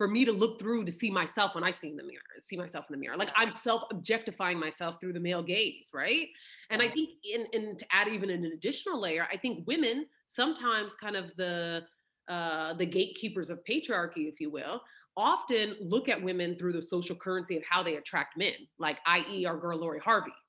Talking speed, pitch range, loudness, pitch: 215 wpm, 170-225 Hz, -32 LUFS, 185 Hz